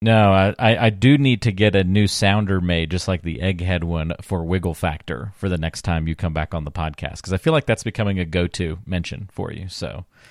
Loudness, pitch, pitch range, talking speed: -21 LUFS, 95 Hz, 85-105 Hz, 245 wpm